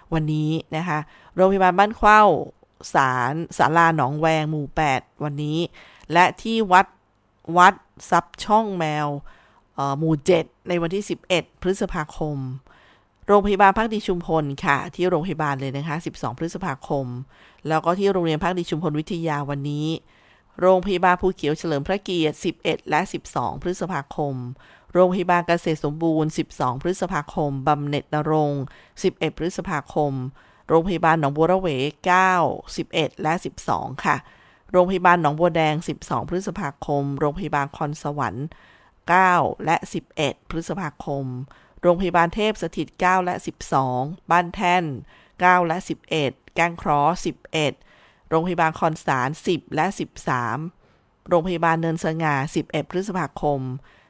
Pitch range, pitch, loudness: 145-180 Hz, 160 Hz, -22 LUFS